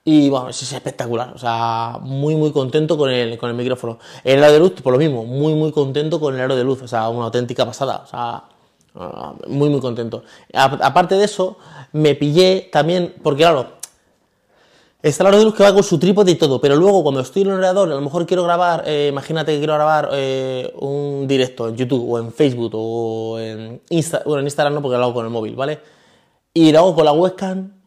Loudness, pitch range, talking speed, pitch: -17 LUFS, 125-165 Hz, 230 wpm, 145 Hz